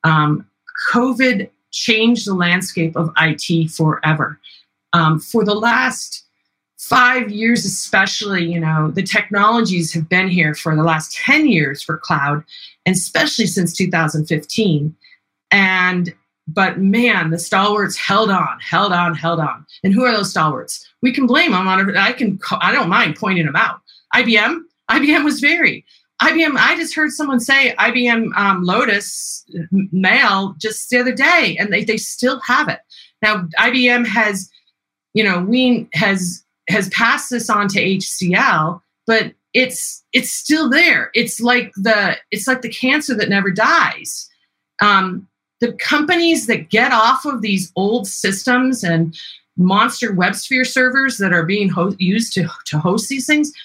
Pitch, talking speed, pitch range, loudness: 205 Hz, 155 wpm, 180-245 Hz, -15 LUFS